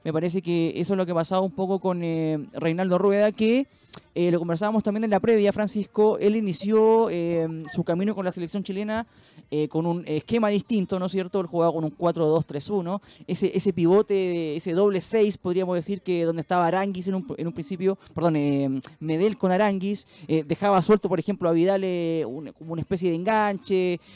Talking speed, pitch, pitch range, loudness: 200 wpm, 185 Hz, 165-200 Hz, -24 LUFS